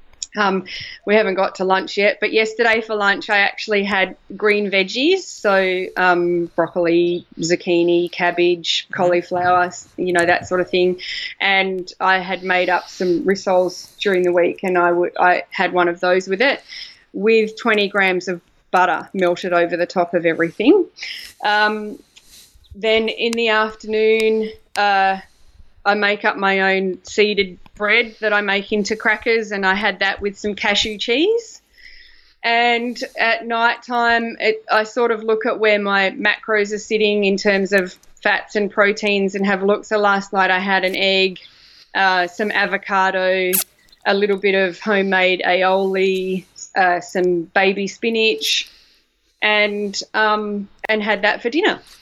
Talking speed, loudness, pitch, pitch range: 155 wpm, -17 LUFS, 200 Hz, 185-215 Hz